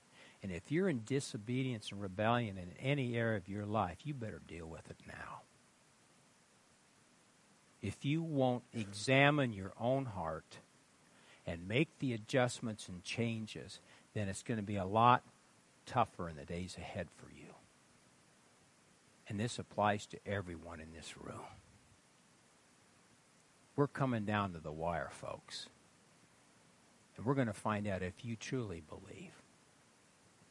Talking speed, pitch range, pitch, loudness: 140 wpm, 95-125 Hz, 110 Hz, -38 LUFS